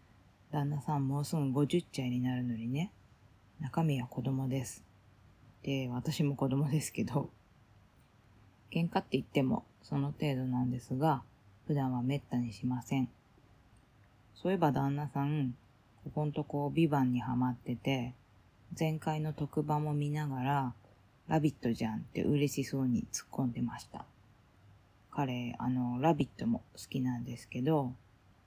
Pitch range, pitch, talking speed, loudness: 120-145 Hz, 130 Hz, 275 characters per minute, -35 LUFS